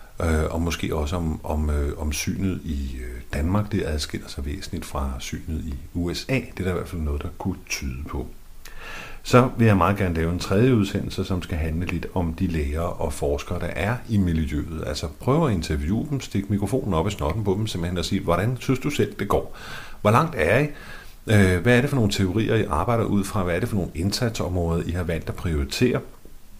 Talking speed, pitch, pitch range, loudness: 220 wpm, 90 Hz, 80-100 Hz, -24 LUFS